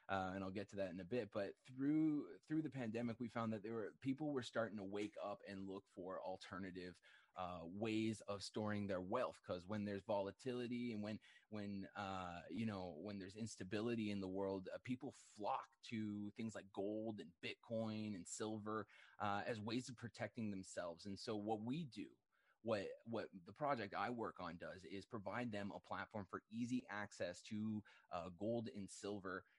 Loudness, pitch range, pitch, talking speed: -48 LUFS, 100-115 Hz, 105 Hz, 190 wpm